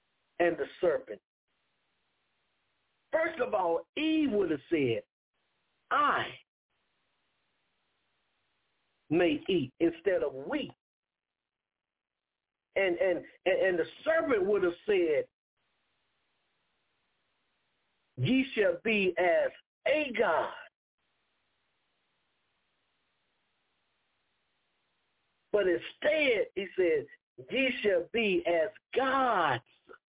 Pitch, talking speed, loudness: 300 Hz, 80 wpm, -30 LUFS